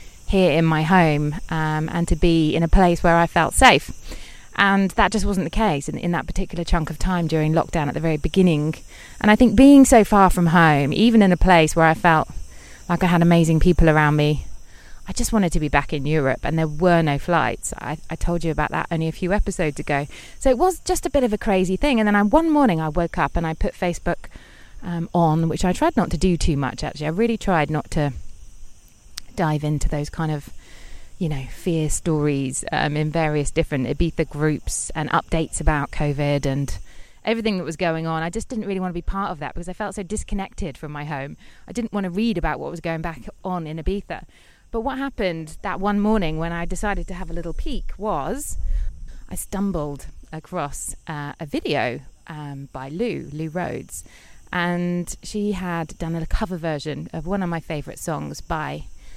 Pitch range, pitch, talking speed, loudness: 150-190 Hz, 165 Hz, 215 wpm, -21 LUFS